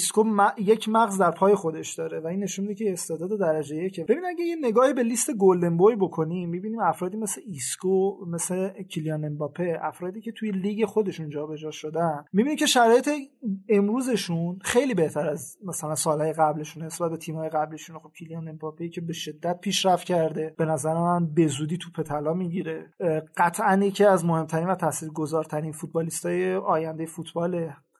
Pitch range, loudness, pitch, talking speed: 160-200 Hz, -25 LUFS, 170 Hz, 165 wpm